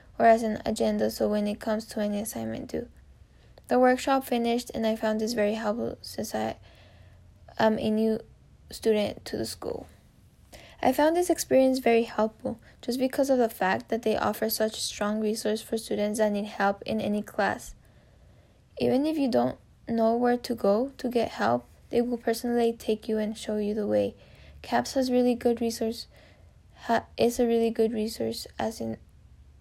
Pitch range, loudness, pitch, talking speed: 200-240 Hz, -27 LUFS, 220 Hz, 180 wpm